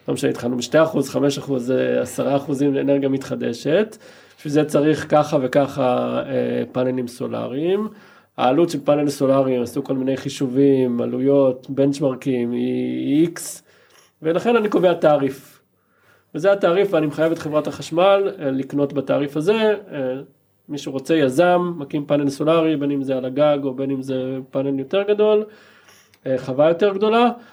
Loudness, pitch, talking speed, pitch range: -20 LUFS, 140 Hz, 140 wpm, 130-160 Hz